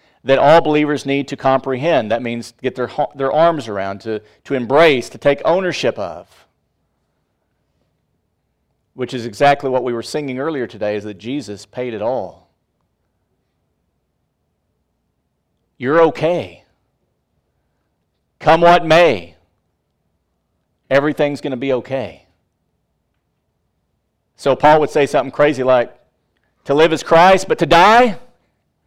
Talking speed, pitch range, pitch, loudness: 125 wpm, 110-150 Hz, 135 Hz, -15 LUFS